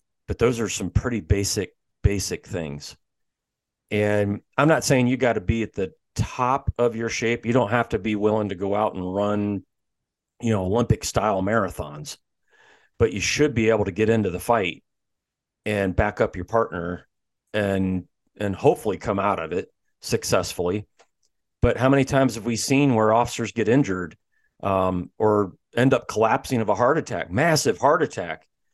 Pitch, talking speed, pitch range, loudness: 105 Hz, 175 wpm, 100-115 Hz, -23 LUFS